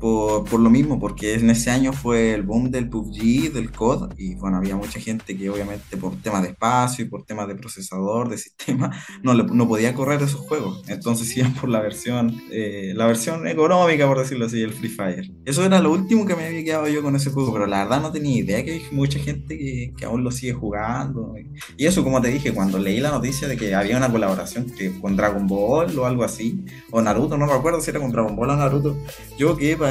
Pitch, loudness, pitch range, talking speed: 120 Hz, -21 LUFS, 105-140 Hz, 235 wpm